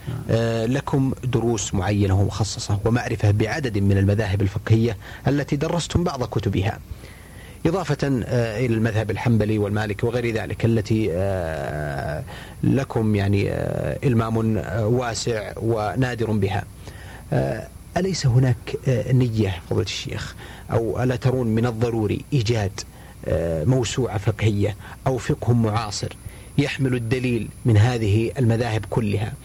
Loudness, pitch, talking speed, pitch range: -22 LUFS, 115 Hz, 100 wpm, 105-125 Hz